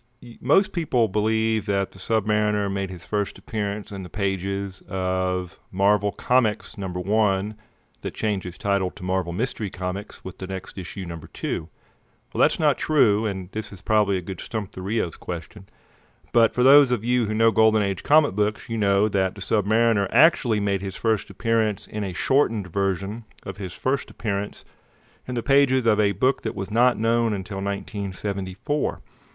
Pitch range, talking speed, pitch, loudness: 95-115 Hz, 180 wpm, 105 Hz, -24 LUFS